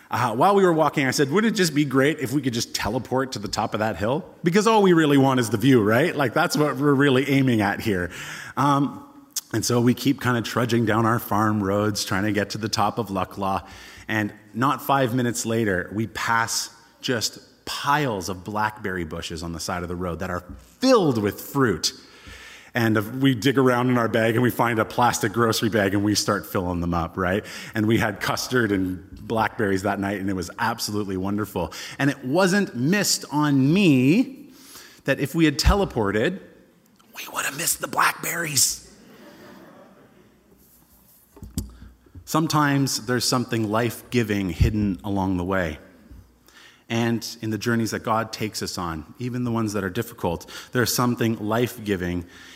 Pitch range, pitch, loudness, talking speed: 100-135 Hz, 115 Hz, -23 LUFS, 185 wpm